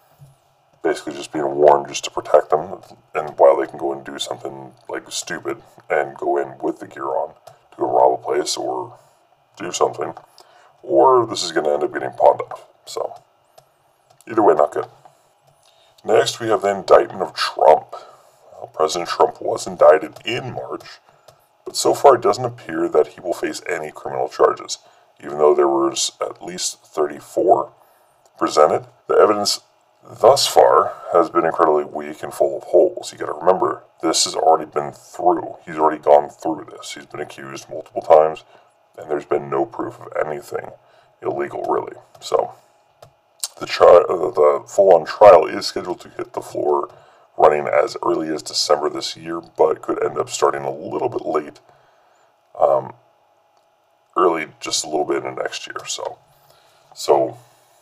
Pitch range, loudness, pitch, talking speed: 70-80 Hz, -18 LUFS, 75 Hz, 170 wpm